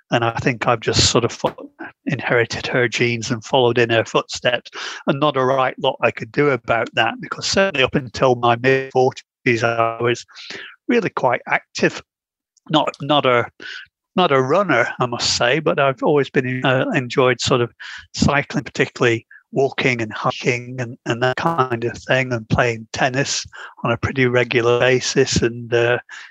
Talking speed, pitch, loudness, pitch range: 170 wpm, 125 Hz, -18 LUFS, 120-135 Hz